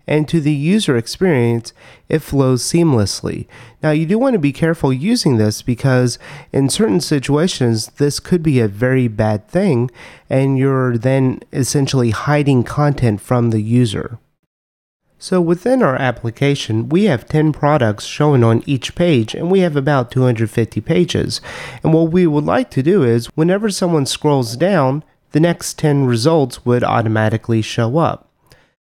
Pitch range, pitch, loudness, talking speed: 120-160 Hz, 135 Hz, -16 LUFS, 155 wpm